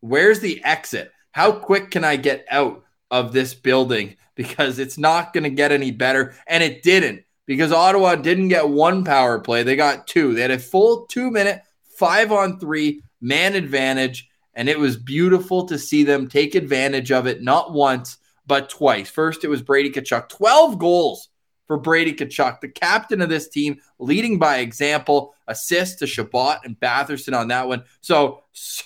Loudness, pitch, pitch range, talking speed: -18 LUFS, 145 Hz, 130-175 Hz, 180 wpm